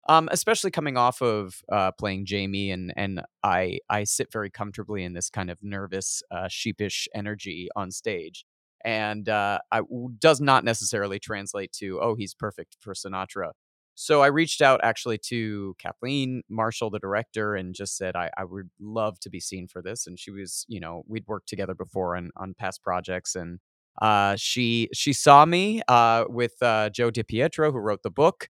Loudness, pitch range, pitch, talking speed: -25 LUFS, 95-120 Hz, 105 Hz, 185 wpm